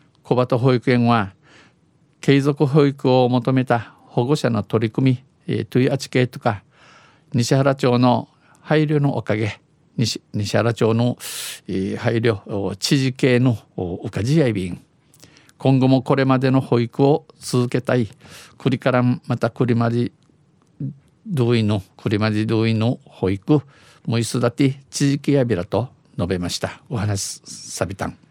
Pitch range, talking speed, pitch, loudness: 115-140 Hz, 250 characters per minute, 125 Hz, -20 LUFS